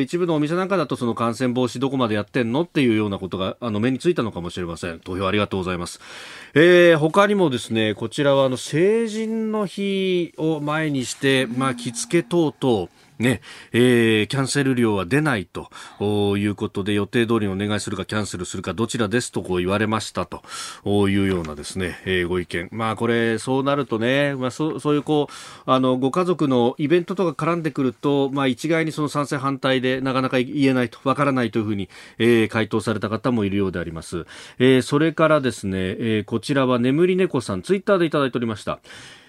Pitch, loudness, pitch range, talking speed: 125 Hz, -21 LUFS, 105-145 Hz, 430 characters per minute